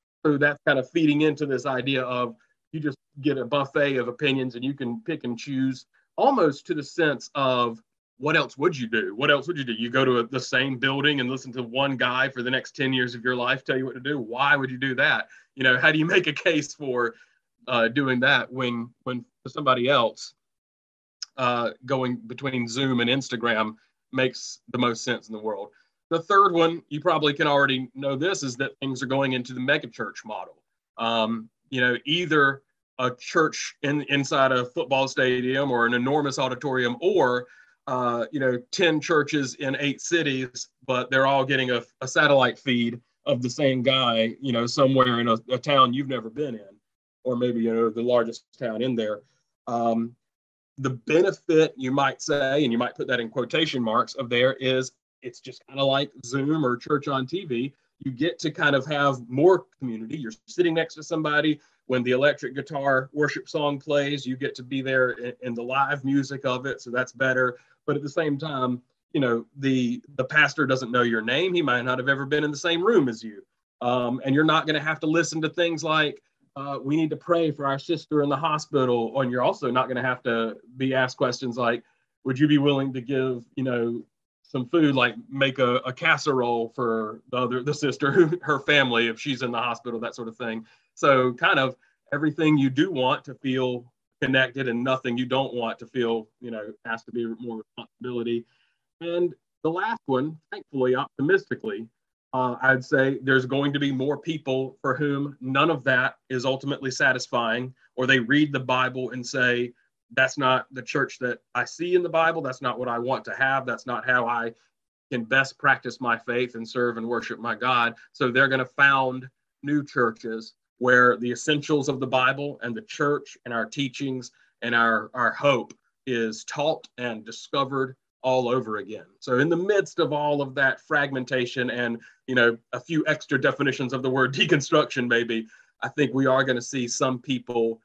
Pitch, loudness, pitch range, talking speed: 130 Hz, -24 LUFS, 125-145 Hz, 205 wpm